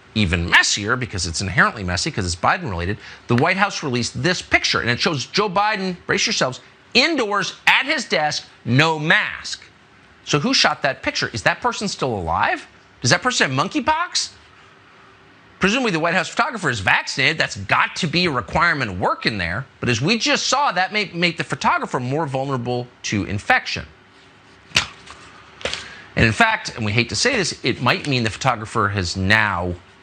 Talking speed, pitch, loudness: 180 wpm, 130 Hz, -19 LUFS